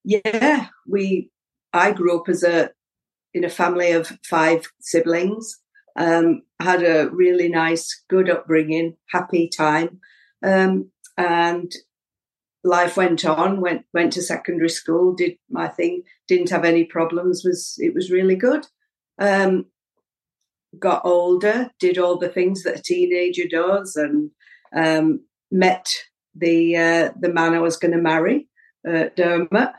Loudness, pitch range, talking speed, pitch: -19 LUFS, 165-195 Hz, 140 wpm, 175 Hz